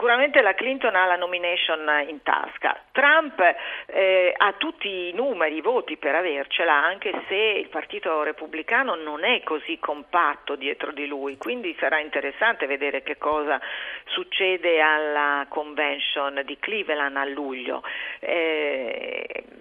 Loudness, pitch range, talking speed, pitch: -23 LUFS, 145-230 Hz, 135 wpm, 160 Hz